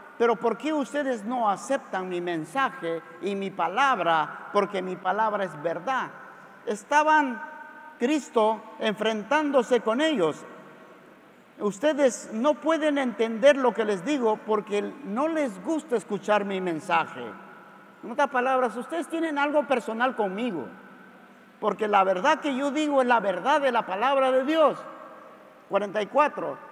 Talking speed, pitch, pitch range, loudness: 135 wpm, 245 Hz, 205-290 Hz, -25 LUFS